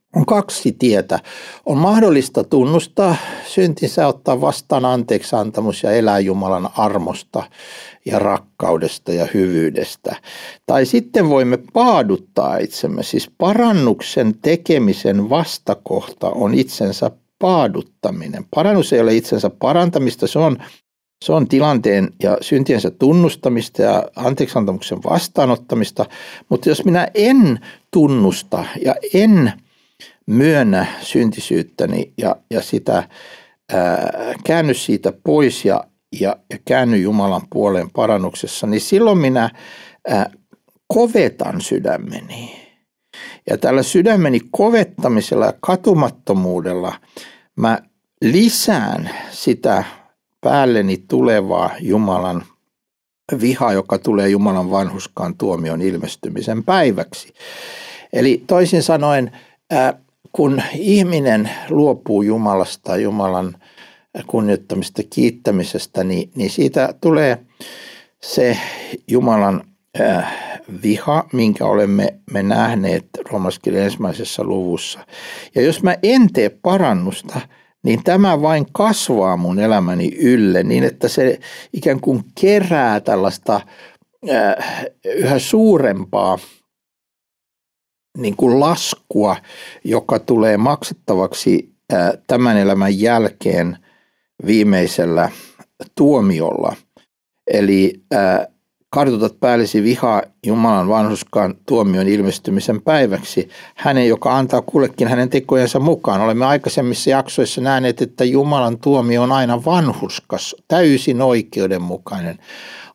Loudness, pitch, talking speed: -16 LUFS, 125 Hz, 95 wpm